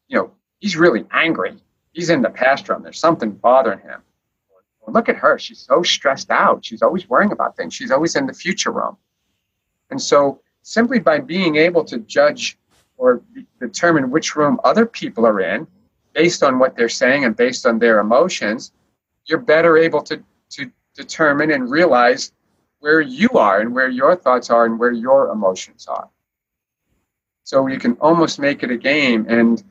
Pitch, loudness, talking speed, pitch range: 155 Hz, -16 LUFS, 180 wpm, 120-175 Hz